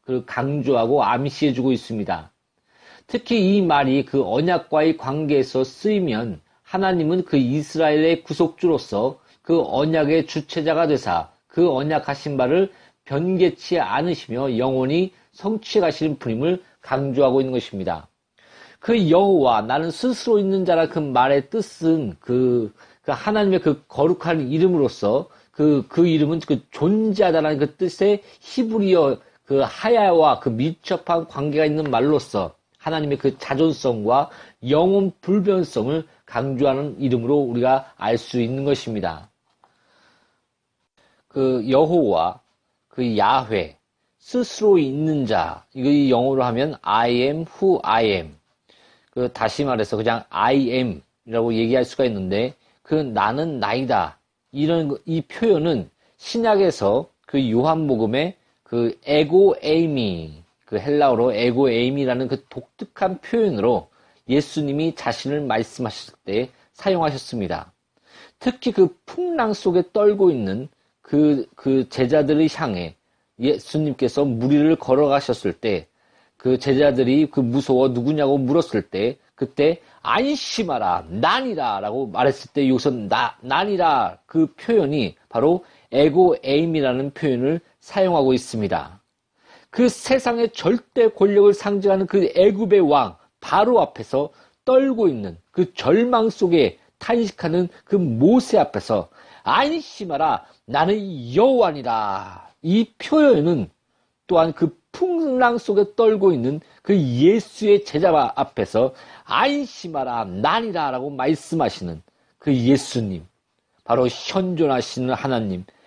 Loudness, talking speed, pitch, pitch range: -20 LUFS, 265 characters per minute, 150 Hz, 130-185 Hz